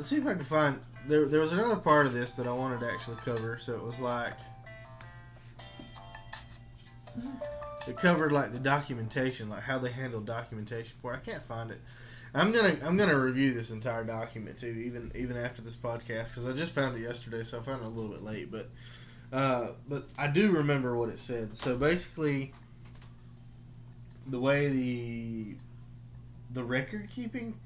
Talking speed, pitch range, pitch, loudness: 180 wpm, 115-135 Hz, 120 Hz, -32 LUFS